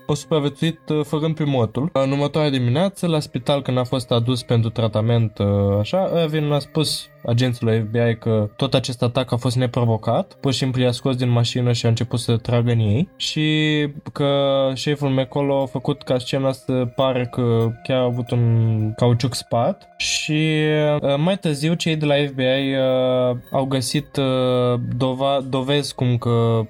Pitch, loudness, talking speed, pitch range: 130 Hz, -20 LUFS, 160 wpm, 120-145 Hz